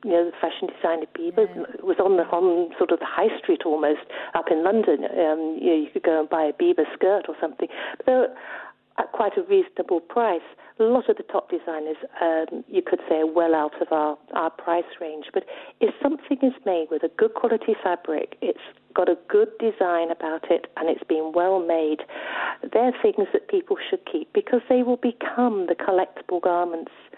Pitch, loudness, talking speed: 200 Hz, -23 LUFS, 205 wpm